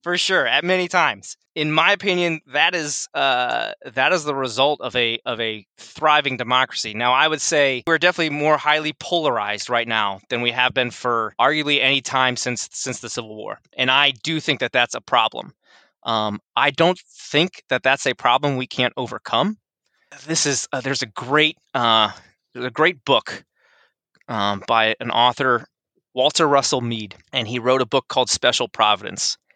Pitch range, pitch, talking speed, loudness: 120-155 Hz, 130 Hz, 185 wpm, -19 LUFS